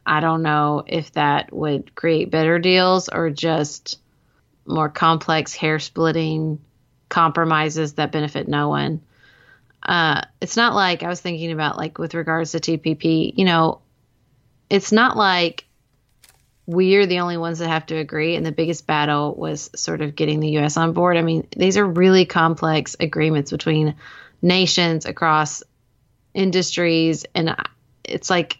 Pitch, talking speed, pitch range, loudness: 160 Hz, 155 wpm, 150-170 Hz, -19 LUFS